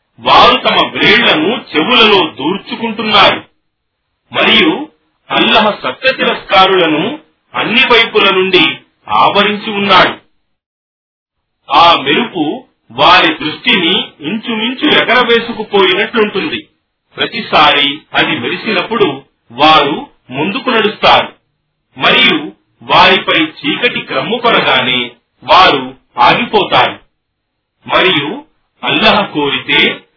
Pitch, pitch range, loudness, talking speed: 200 Hz, 145-230 Hz, -9 LUFS, 65 wpm